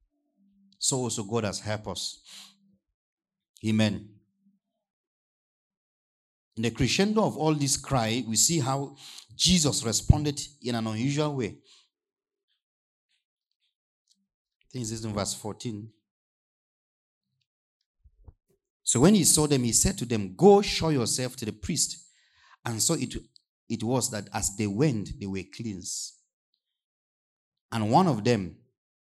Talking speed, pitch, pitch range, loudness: 125 wpm, 125 Hz, 110-170 Hz, -26 LUFS